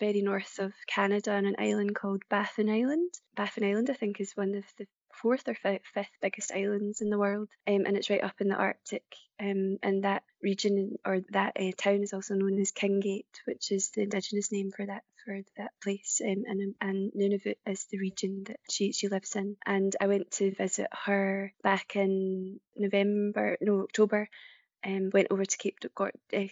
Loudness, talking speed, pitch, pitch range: -31 LUFS, 200 wpm, 200 Hz, 195-205 Hz